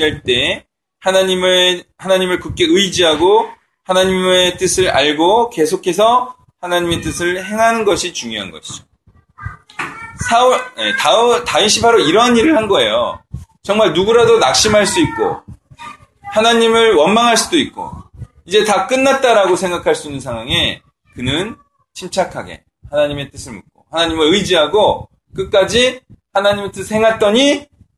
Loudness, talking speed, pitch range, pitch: -13 LUFS, 295 characters per minute, 175-235 Hz, 195 Hz